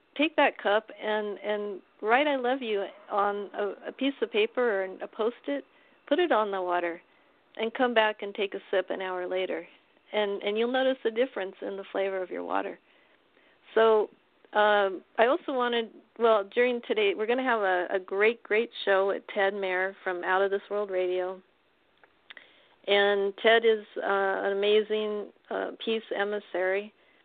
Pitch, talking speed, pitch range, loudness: 210 Hz, 175 wpm, 195-240 Hz, -28 LUFS